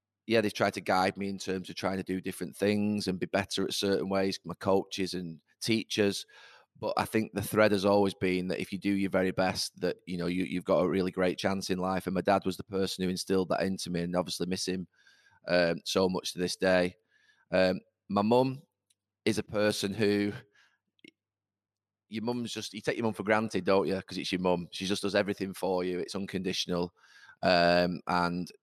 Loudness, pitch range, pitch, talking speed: -30 LUFS, 90-100 Hz, 95 Hz, 220 wpm